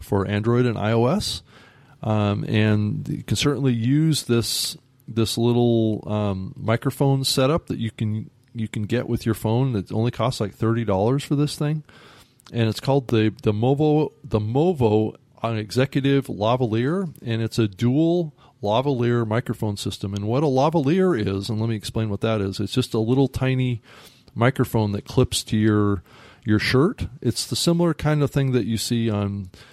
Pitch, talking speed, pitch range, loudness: 120 Hz, 175 wpm, 110-135 Hz, -22 LUFS